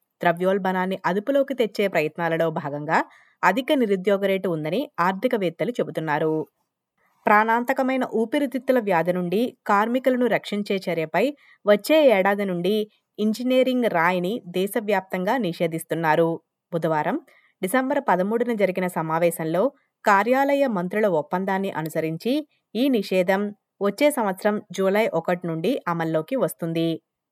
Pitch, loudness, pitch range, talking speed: 195 Hz, -23 LUFS, 170-245 Hz, 95 wpm